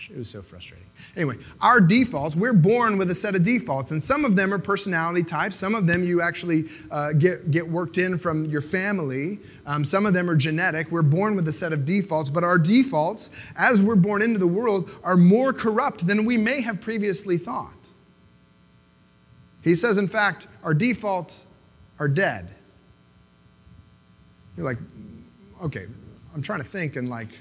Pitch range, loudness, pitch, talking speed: 145-200 Hz, -22 LUFS, 175 Hz, 180 wpm